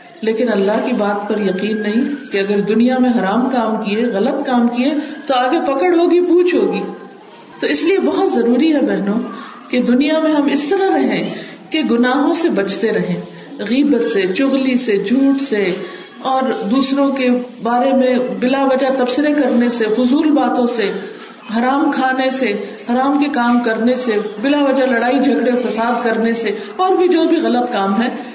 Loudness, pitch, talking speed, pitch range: -15 LUFS, 250 Hz, 175 wpm, 230-275 Hz